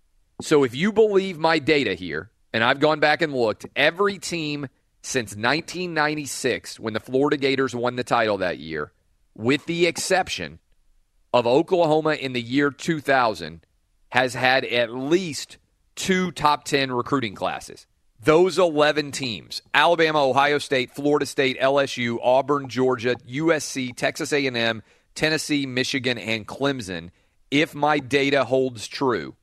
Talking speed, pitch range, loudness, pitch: 135 wpm, 125-155 Hz, -22 LUFS, 140 Hz